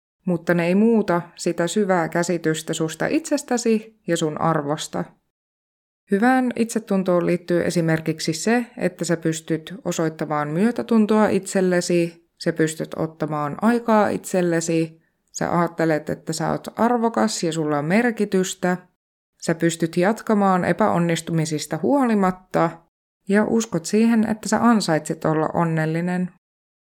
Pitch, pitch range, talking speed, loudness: 175 Hz, 165-215 Hz, 115 wpm, -21 LUFS